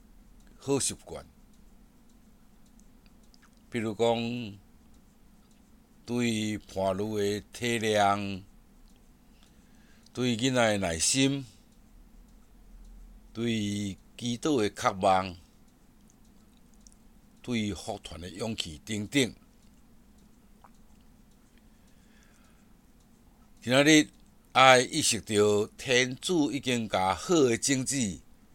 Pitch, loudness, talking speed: 120 Hz, -27 LUFS, 110 characters per minute